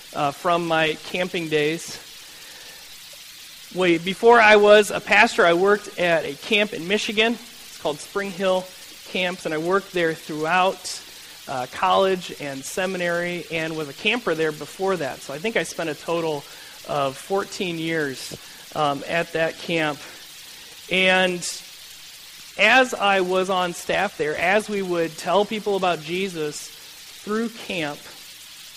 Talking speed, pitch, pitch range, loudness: 145 wpm, 180 Hz, 160-195 Hz, -21 LUFS